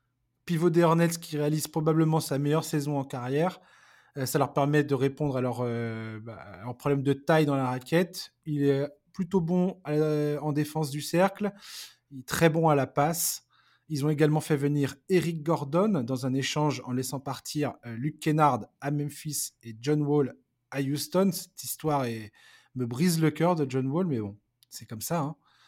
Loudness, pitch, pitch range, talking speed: -28 LUFS, 145 Hz, 130-160 Hz, 195 wpm